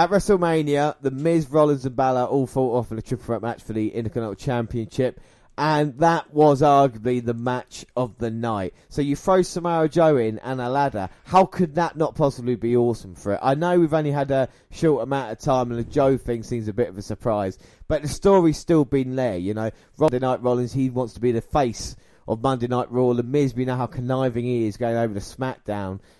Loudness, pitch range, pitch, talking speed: -22 LUFS, 115-145 Hz, 125 Hz, 225 wpm